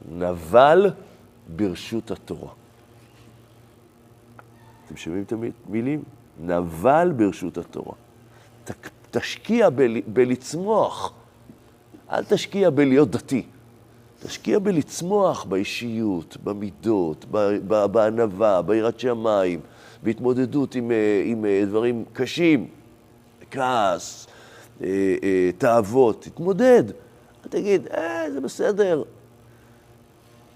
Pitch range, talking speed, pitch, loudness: 105-125 Hz, 75 wpm, 120 Hz, -22 LUFS